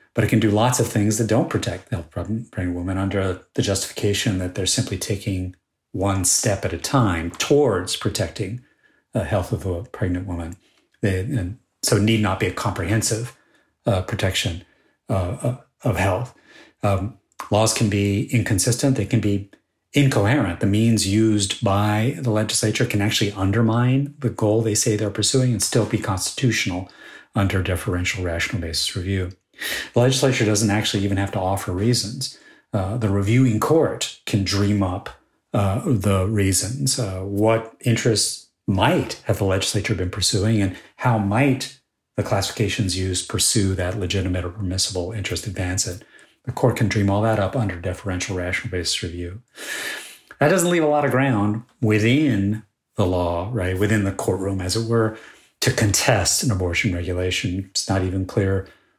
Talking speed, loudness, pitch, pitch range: 165 wpm, -21 LUFS, 105 Hz, 95-115 Hz